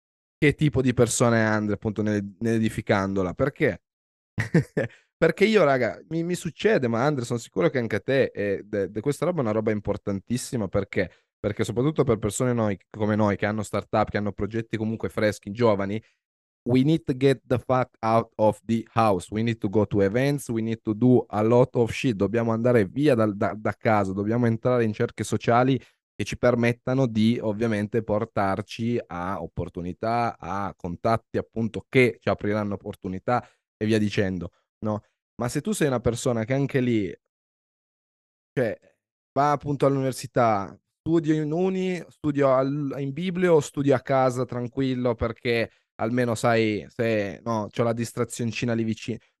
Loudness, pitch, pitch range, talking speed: -25 LUFS, 115 Hz, 105-130 Hz, 170 wpm